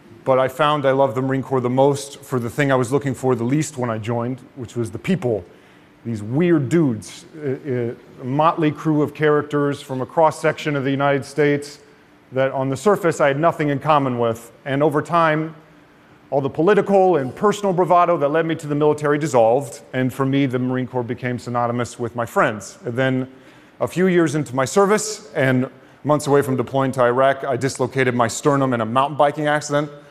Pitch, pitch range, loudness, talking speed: 140 Hz, 130-150 Hz, -19 LUFS, 205 wpm